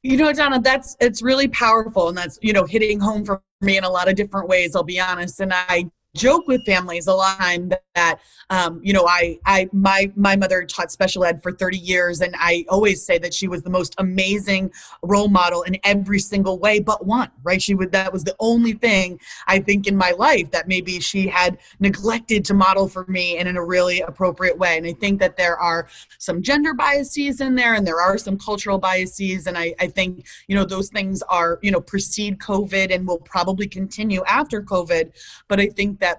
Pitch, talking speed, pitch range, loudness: 190 Hz, 220 wpm, 180-205 Hz, -19 LUFS